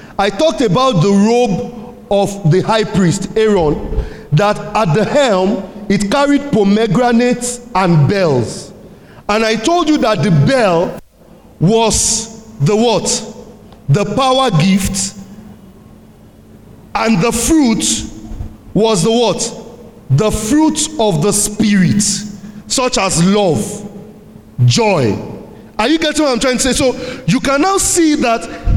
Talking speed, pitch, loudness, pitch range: 125 wpm, 215 Hz, -13 LUFS, 190-240 Hz